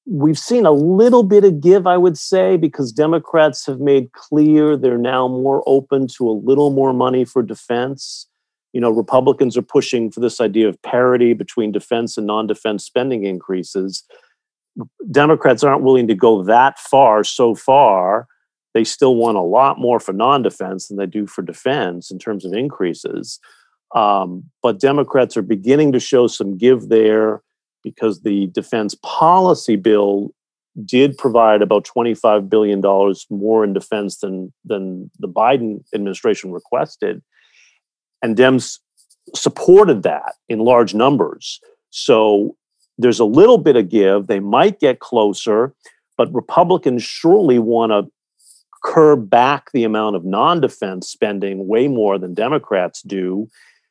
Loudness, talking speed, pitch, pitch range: -15 LUFS, 150 wpm, 115 Hz, 105-140 Hz